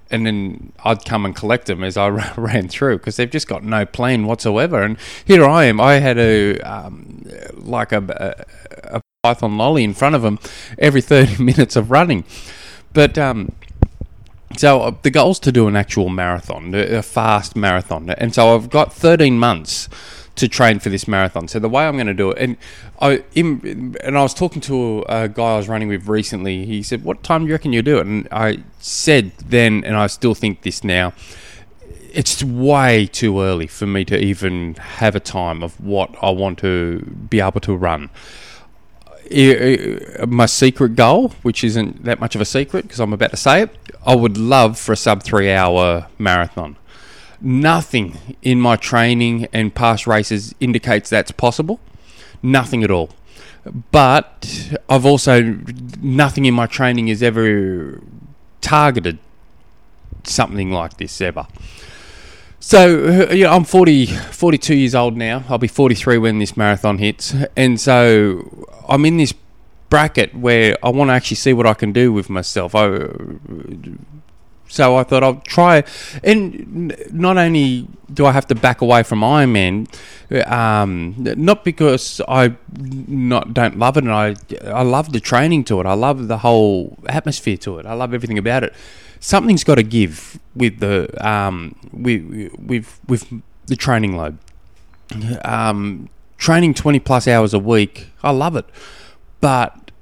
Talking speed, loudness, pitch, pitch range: 170 wpm, -15 LUFS, 115 Hz, 100-130 Hz